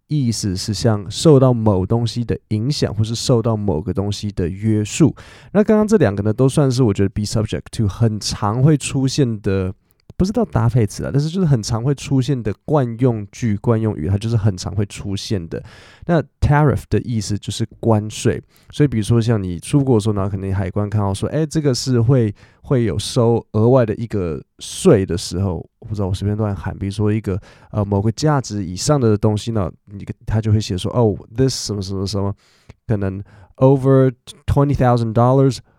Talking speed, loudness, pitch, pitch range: 345 characters per minute, -18 LUFS, 110 Hz, 100-130 Hz